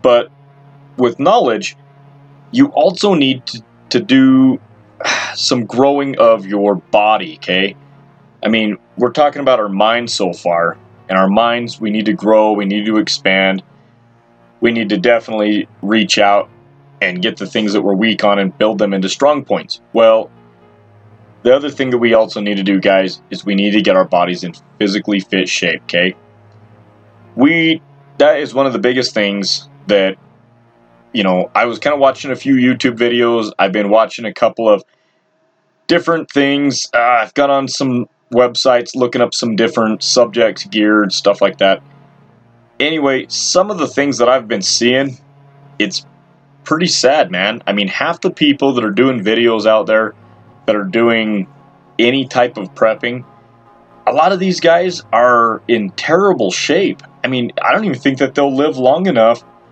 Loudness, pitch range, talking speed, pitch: -13 LUFS, 105-140 Hz, 175 wpm, 120 Hz